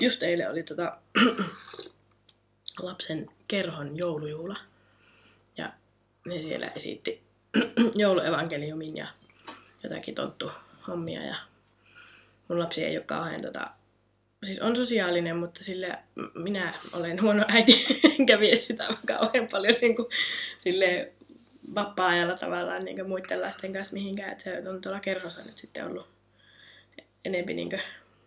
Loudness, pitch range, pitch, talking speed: -27 LUFS, 160-215 Hz, 185 Hz, 125 wpm